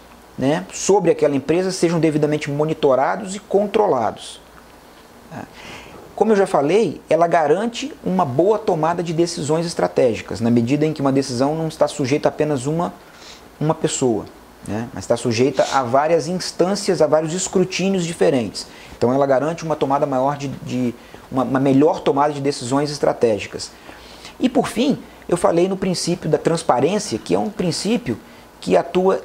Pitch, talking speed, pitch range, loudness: 155 Hz, 160 wpm, 140-180 Hz, -19 LUFS